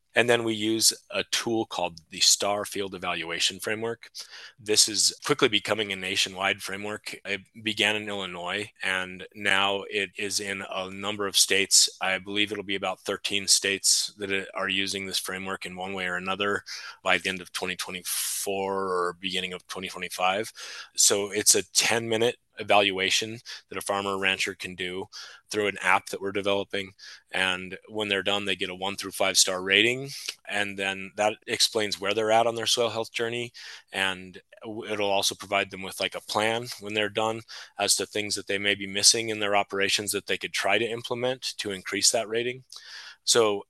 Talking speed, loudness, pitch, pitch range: 185 wpm, -25 LUFS, 100 Hz, 95-105 Hz